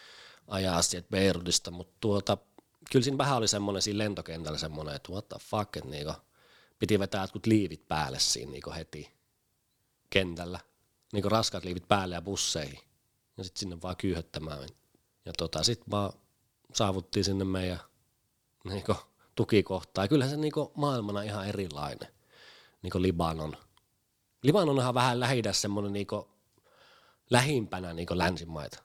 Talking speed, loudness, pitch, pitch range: 140 wpm, -31 LUFS, 100 Hz, 90-110 Hz